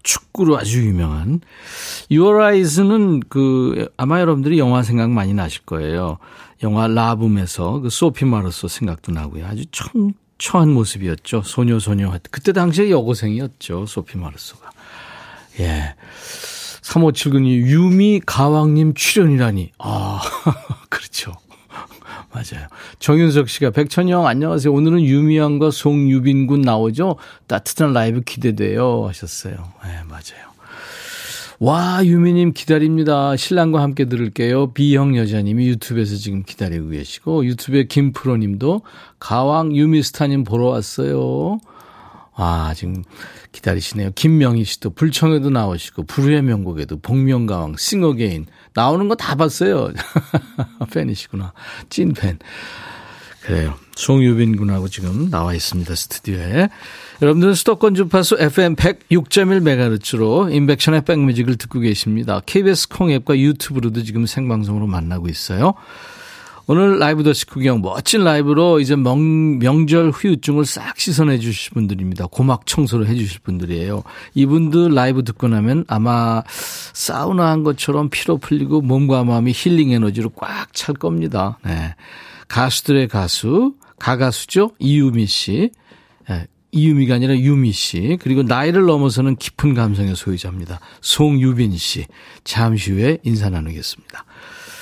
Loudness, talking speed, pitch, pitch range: -17 LUFS, 310 characters per minute, 130 Hz, 105-155 Hz